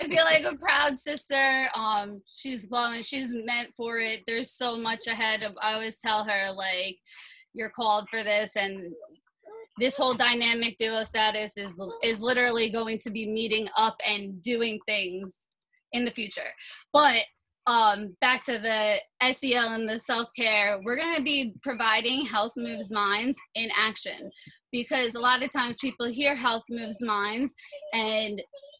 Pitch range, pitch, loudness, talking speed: 215-255 Hz, 230 Hz, -25 LUFS, 160 wpm